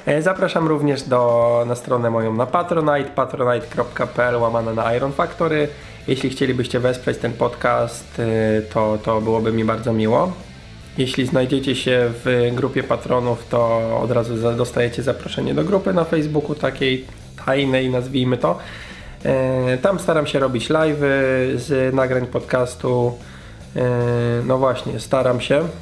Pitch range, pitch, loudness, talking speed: 120-140 Hz, 125 Hz, -19 LUFS, 130 wpm